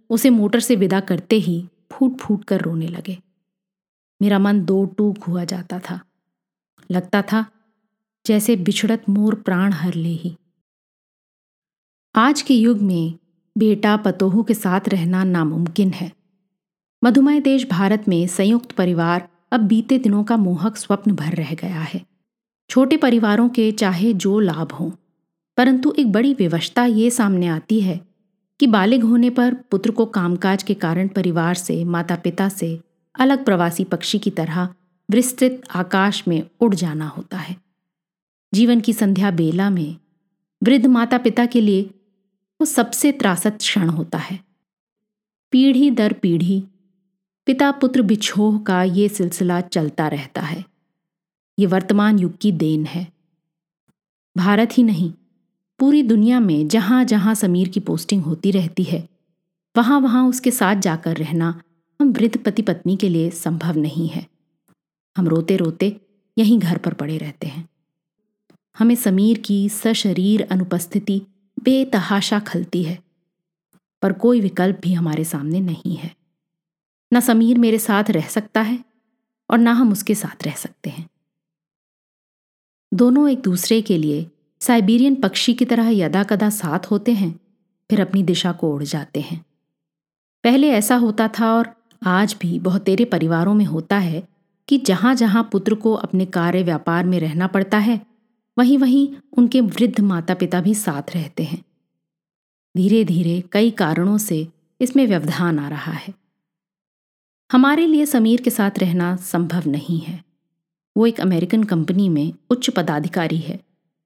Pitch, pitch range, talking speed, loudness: 195 Hz, 175-225 Hz, 150 wpm, -18 LUFS